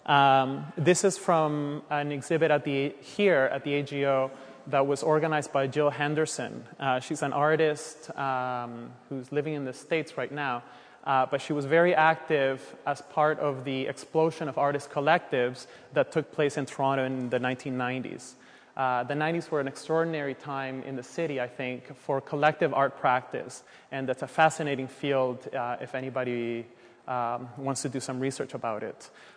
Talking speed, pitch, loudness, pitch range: 170 wpm, 140 Hz, -28 LUFS, 130-150 Hz